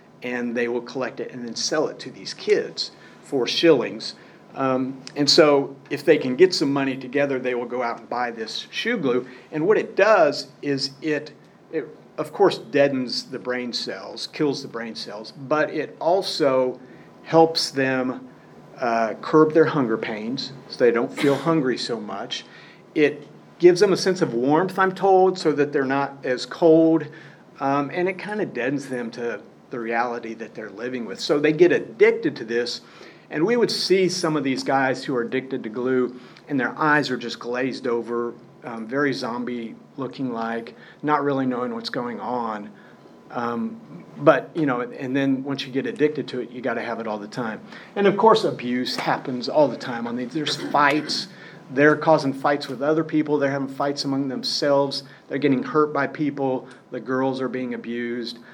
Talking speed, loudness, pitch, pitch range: 195 wpm, -22 LUFS, 135 Hz, 125-150 Hz